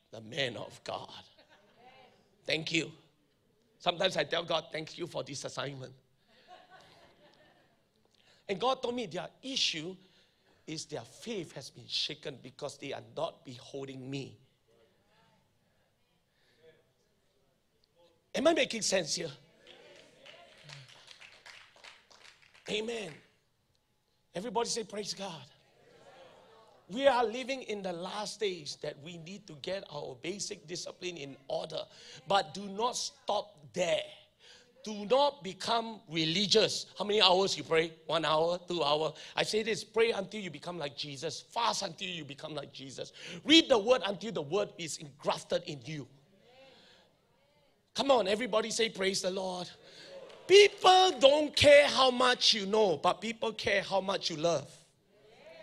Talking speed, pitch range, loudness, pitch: 135 wpm, 155-225 Hz, -31 LUFS, 190 Hz